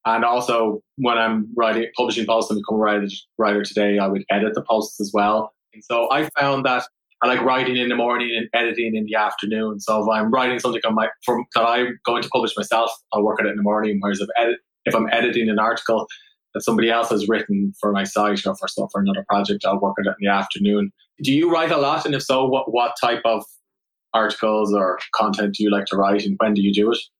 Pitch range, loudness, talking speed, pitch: 105-120 Hz, -20 LUFS, 245 wpm, 110 Hz